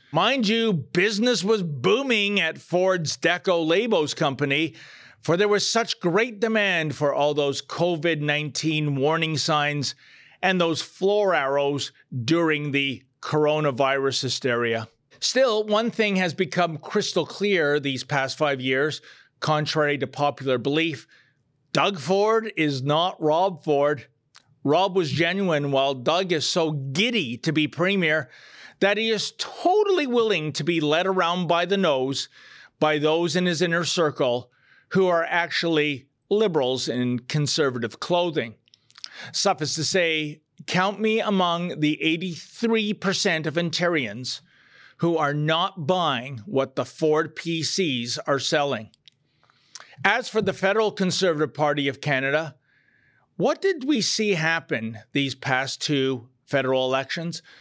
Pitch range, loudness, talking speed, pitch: 140-190 Hz, -23 LUFS, 130 wpm, 160 Hz